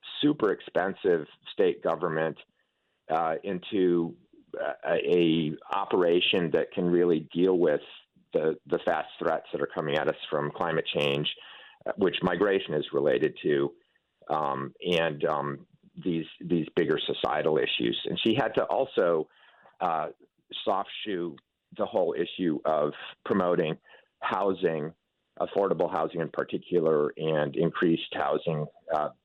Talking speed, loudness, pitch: 125 wpm, -28 LUFS, 305 Hz